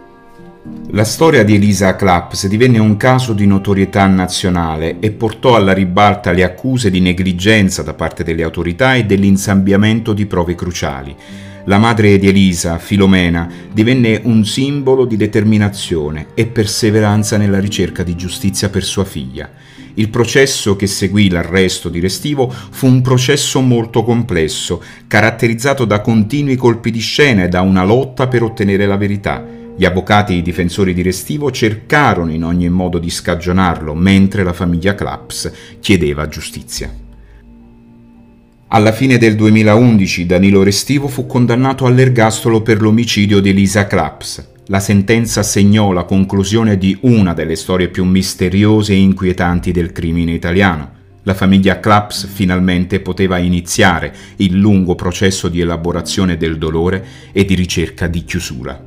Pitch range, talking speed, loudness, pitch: 90-110 Hz, 145 wpm, -12 LUFS, 100 Hz